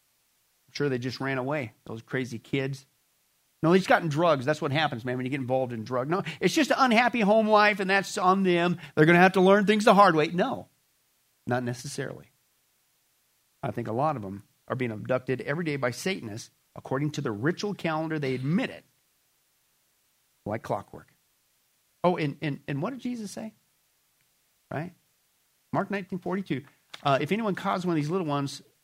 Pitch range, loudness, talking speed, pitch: 130-185 Hz, -26 LUFS, 190 wpm, 150 Hz